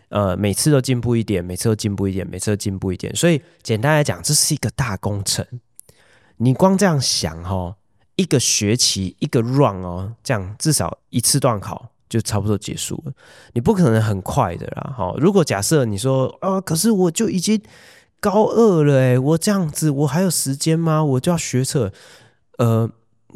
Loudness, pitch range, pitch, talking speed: -19 LUFS, 105-155 Hz, 125 Hz, 285 characters per minute